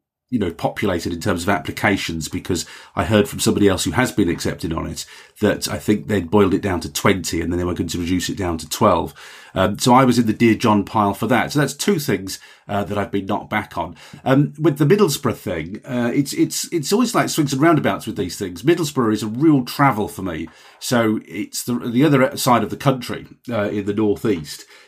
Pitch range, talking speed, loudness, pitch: 100-140 Hz, 235 wpm, -19 LUFS, 110 Hz